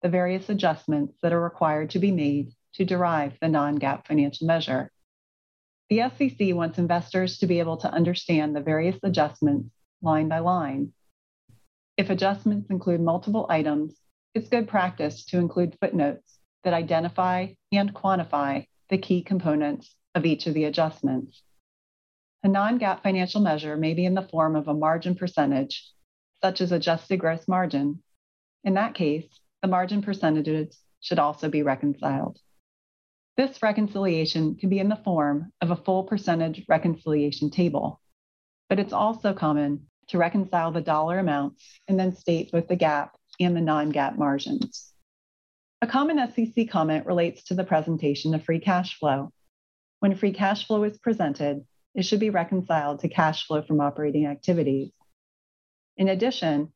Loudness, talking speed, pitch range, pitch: -25 LUFS, 150 wpm, 150-190 Hz, 165 Hz